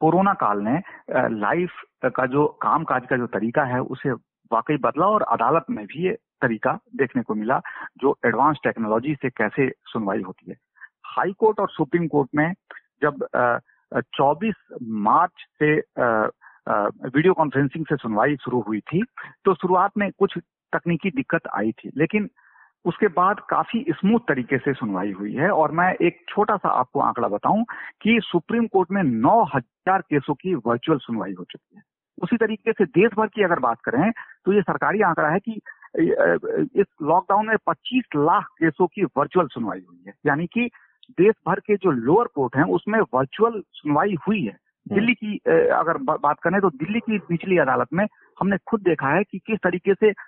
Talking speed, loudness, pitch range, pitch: 175 wpm, -22 LUFS, 145-205 Hz, 175 Hz